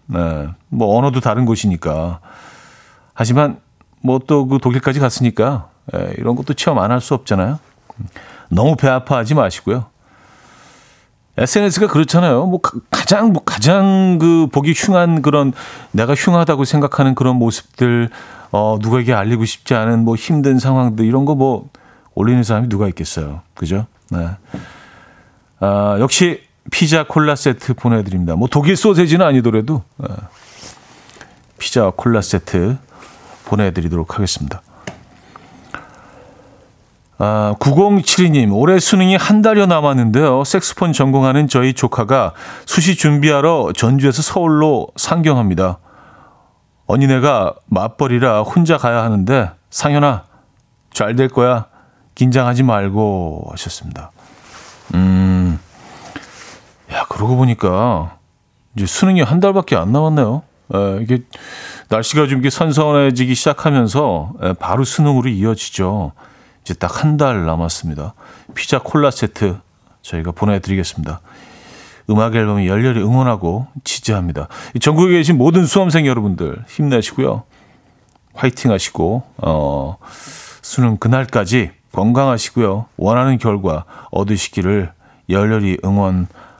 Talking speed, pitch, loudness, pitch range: 275 characters per minute, 125 Hz, -15 LUFS, 100-145 Hz